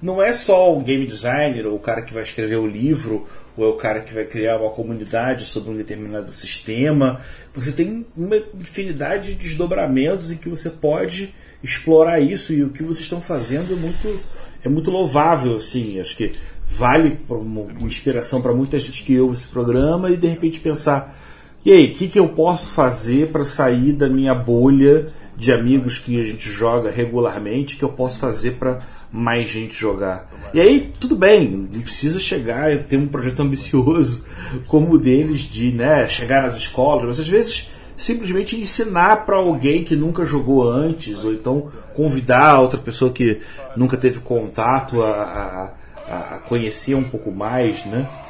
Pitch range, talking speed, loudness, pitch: 115-160 Hz, 180 wpm, -18 LUFS, 135 Hz